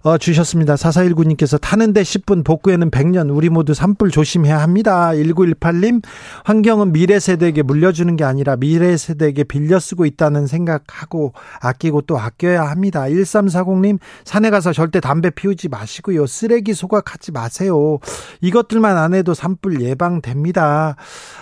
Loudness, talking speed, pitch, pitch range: -15 LUFS, 325 characters per minute, 170 Hz, 150-190 Hz